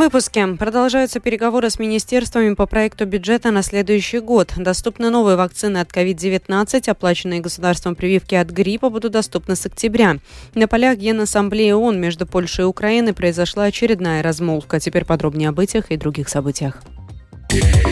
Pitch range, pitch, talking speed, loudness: 175-225 Hz, 200 Hz, 145 wpm, -17 LUFS